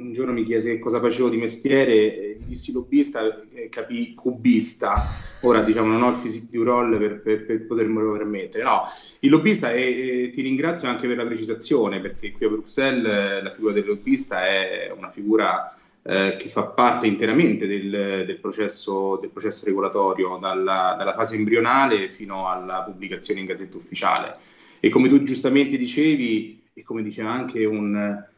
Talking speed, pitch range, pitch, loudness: 165 wpm, 105-130 Hz, 115 Hz, -22 LUFS